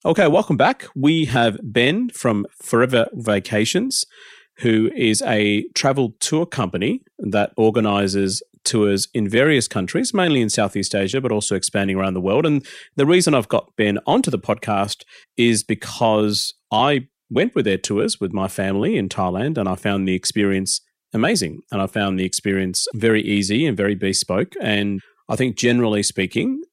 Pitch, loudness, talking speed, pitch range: 105 Hz, -19 LUFS, 165 wpm, 100-125 Hz